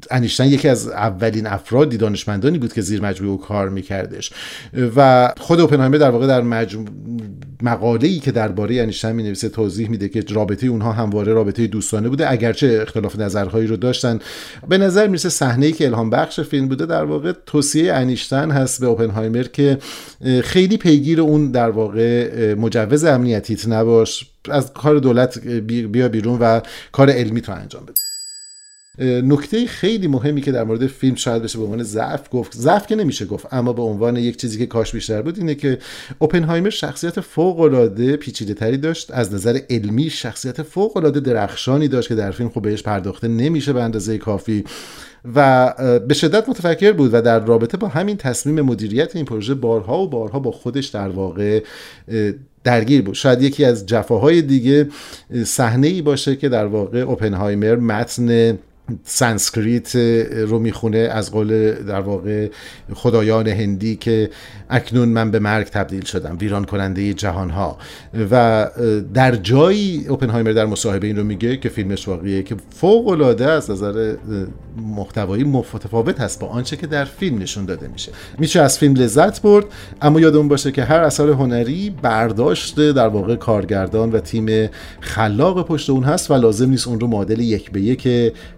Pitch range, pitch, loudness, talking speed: 110-140 Hz, 120 Hz, -17 LUFS, 165 wpm